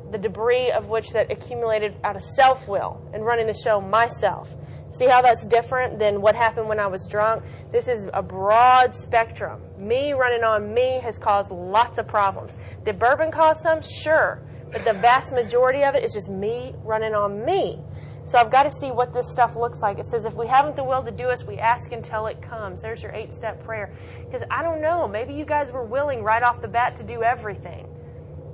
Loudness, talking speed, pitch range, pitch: -22 LUFS, 215 wpm, 220-260 Hz, 235 Hz